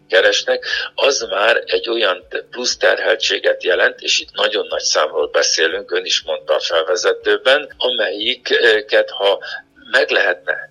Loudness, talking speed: -16 LUFS, 130 wpm